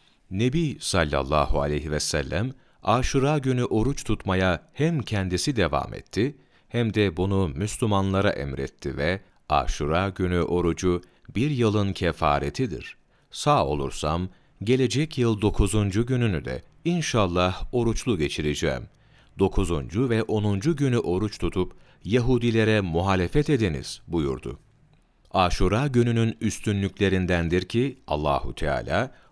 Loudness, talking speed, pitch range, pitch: -25 LUFS, 105 wpm, 85-120 Hz, 100 Hz